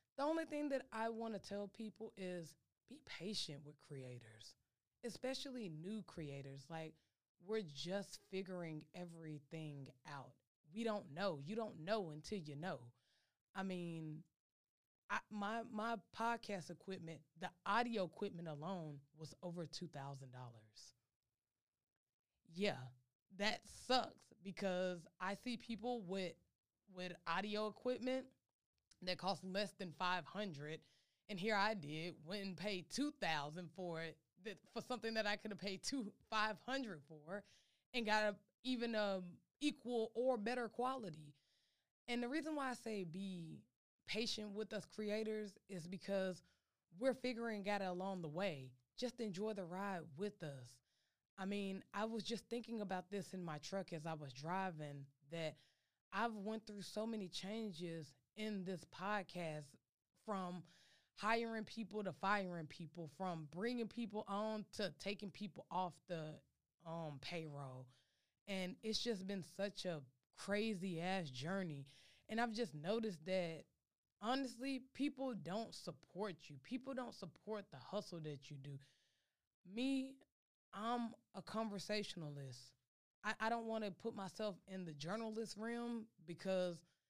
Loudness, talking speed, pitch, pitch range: -46 LUFS, 140 wpm, 190 Hz, 160-220 Hz